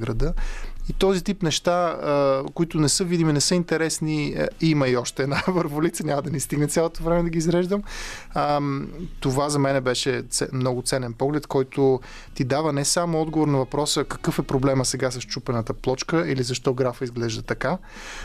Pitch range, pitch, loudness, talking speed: 135-165 Hz, 145 Hz, -23 LUFS, 175 wpm